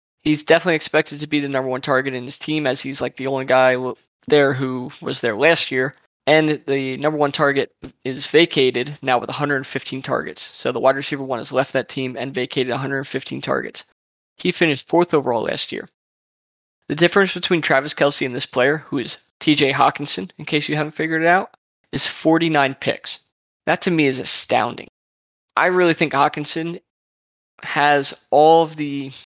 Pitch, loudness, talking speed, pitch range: 140 Hz, -19 LUFS, 180 wpm, 130-155 Hz